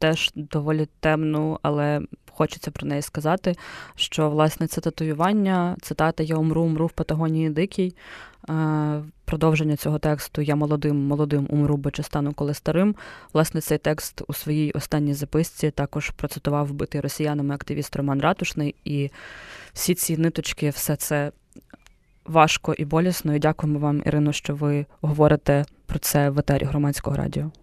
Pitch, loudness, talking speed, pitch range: 150 Hz, -24 LUFS, 145 wpm, 145-160 Hz